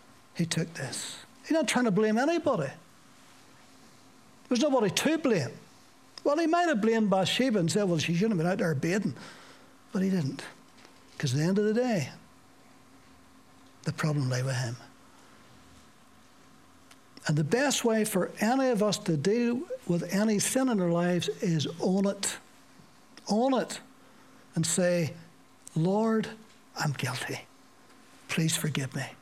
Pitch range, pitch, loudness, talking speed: 165-240 Hz, 200 Hz, -28 LUFS, 150 wpm